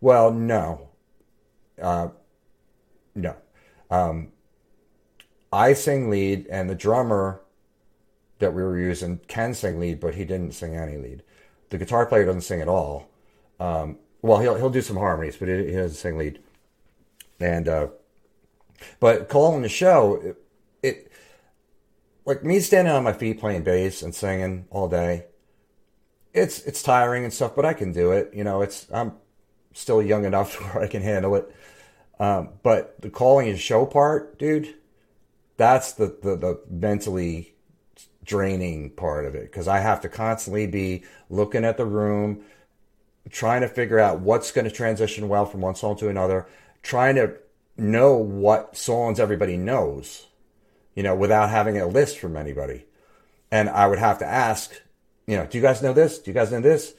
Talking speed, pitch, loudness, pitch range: 165 wpm, 105 Hz, -23 LUFS, 95-115 Hz